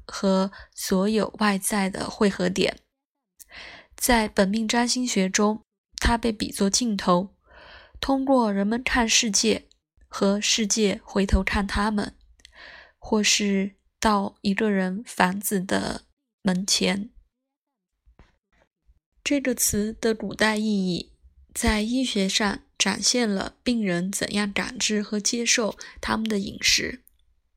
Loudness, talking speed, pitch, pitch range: -23 LUFS, 170 characters per minute, 210 Hz, 195-230 Hz